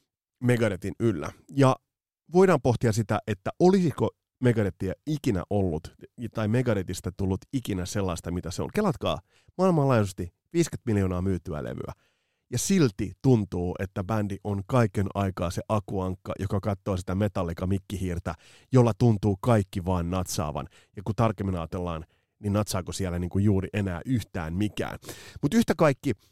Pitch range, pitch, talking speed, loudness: 95-120 Hz, 105 Hz, 135 wpm, -27 LUFS